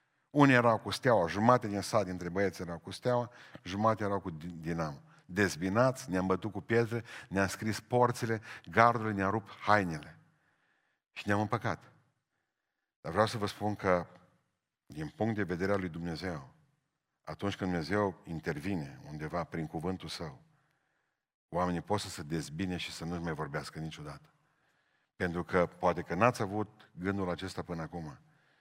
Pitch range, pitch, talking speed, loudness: 85-110 Hz, 95 Hz, 155 wpm, -33 LUFS